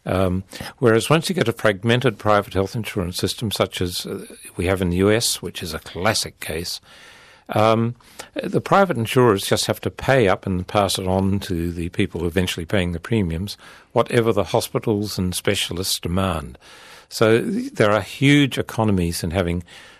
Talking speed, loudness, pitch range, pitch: 170 wpm, -21 LUFS, 95-115 Hz, 100 Hz